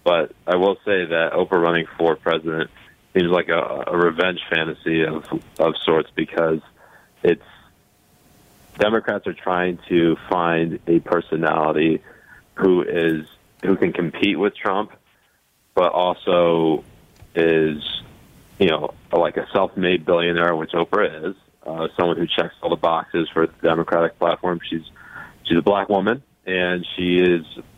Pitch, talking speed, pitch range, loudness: 85 Hz, 145 wpm, 80-90 Hz, -20 LUFS